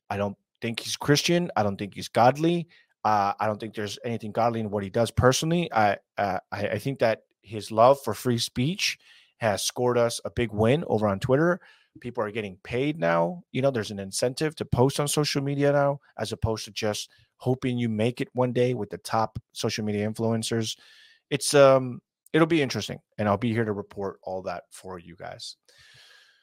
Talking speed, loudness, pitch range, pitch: 205 wpm, -26 LUFS, 105-140 Hz, 115 Hz